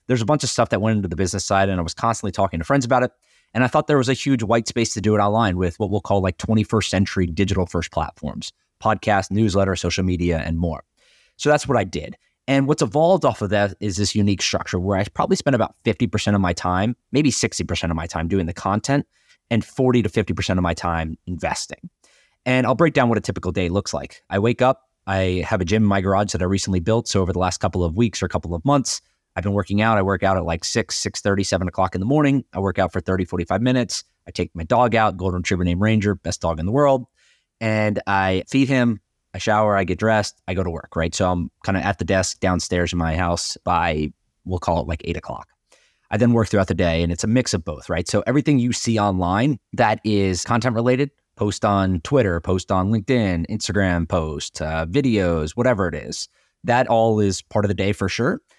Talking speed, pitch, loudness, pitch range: 250 wpm, 100 Hz, -21 LUFS, 90-115 Hz